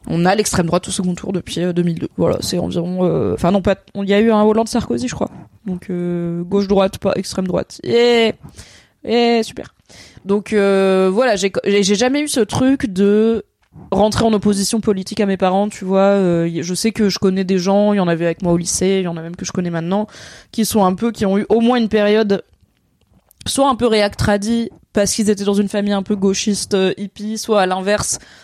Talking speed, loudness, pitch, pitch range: 235 wpm, -16 LUFS, 200 Hz, 185-215 Hz